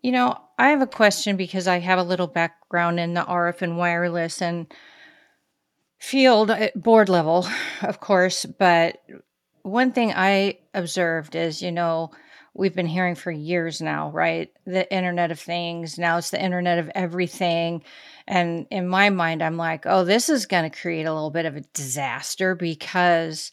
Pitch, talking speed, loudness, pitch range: 175 Hz, 170 wpm, -22 LUFS, 170-195 Hz